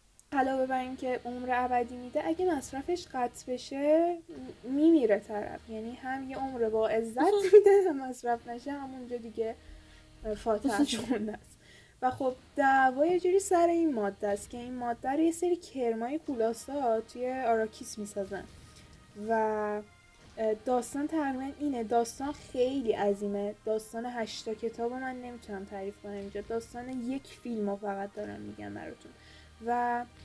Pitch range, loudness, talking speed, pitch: 220-270 Hz, -31 LUFS, 140 wpm, 245 Hz